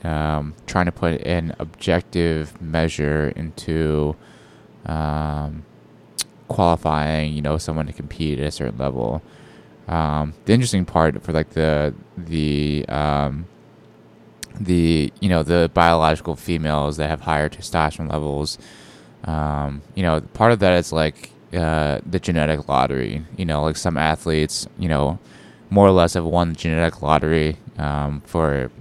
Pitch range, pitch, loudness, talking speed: 75-85 Hz, 80 Hz, -21 LUFS, 140 wpm